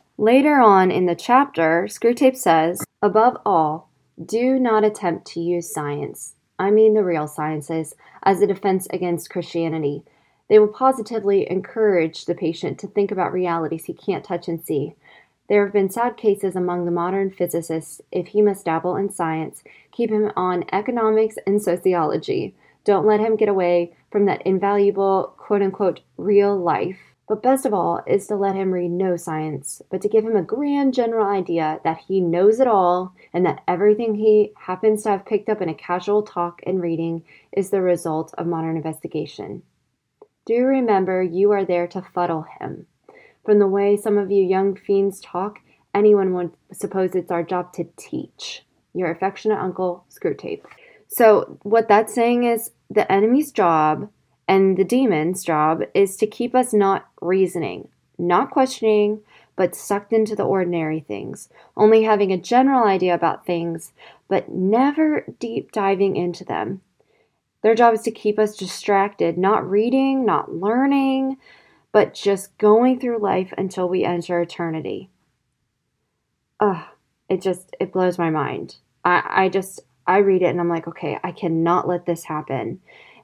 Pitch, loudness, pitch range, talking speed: 195 Hz, -20 LUFS, 175-215 Hz, 165 wpm